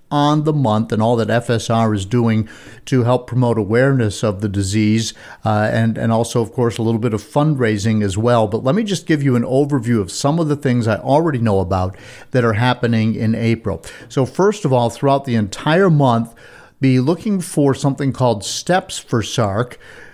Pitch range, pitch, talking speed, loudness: 110-140 Hz, 120 Hz, 200 wpm, -17 LUFS